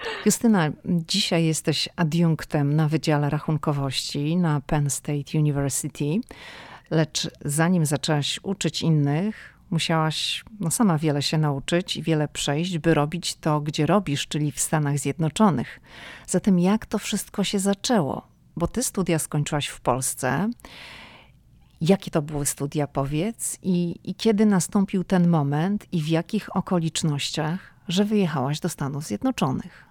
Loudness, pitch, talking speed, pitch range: -24 LUFS, 160 Hz, 130 wpm, 150-185 Hz